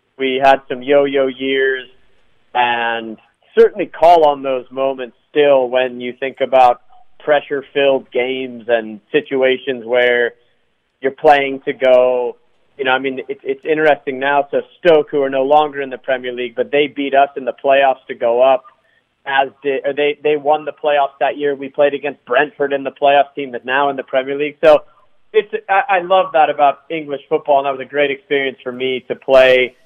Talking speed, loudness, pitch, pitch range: 195 wpm, -15 LUFS, 135 Hz, 130-145 Hz